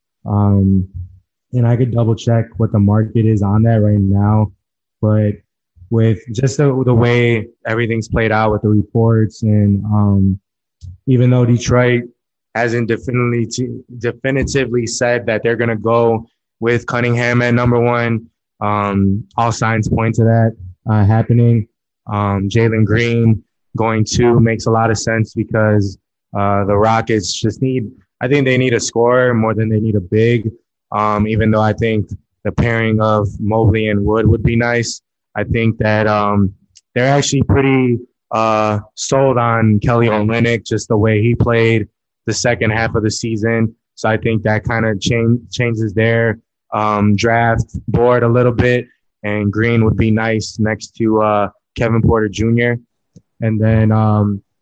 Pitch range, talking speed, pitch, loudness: 105-120 Hz, 160 wpm, 115 Hz, -15 LUFS